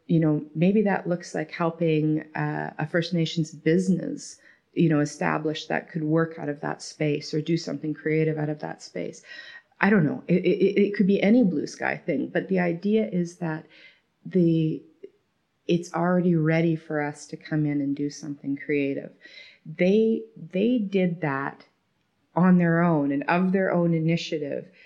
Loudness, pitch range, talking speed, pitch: -25 LUFS, 155-180 Hz, 175 wpm, 165 Hz